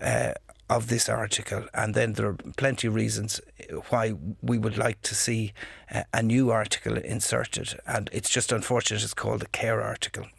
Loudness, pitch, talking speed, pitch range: -27 LUFS, 110 Hz, 175 wpm, 105-120 Hz